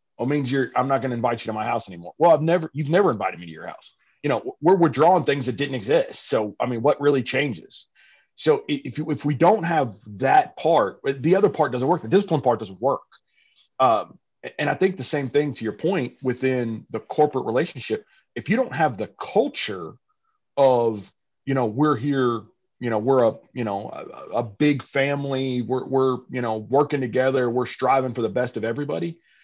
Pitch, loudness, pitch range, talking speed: 135 Hz, -23 LUFS, 125-150 Hz, 210 wpm